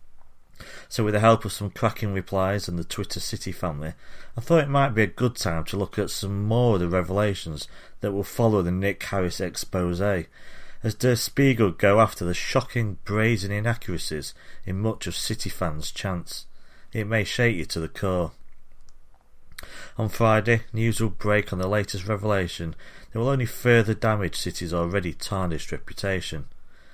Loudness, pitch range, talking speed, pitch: -25 LUFS, 90-110 Hz, 170 wpm, 100 Hz